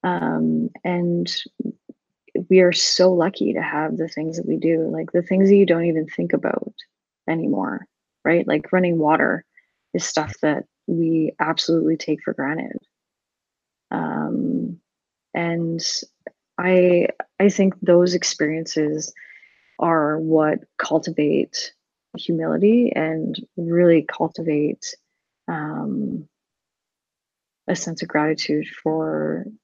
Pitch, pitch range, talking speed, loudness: 165 Hz, 155-180 Hz, 110 wpm, -21 LUFS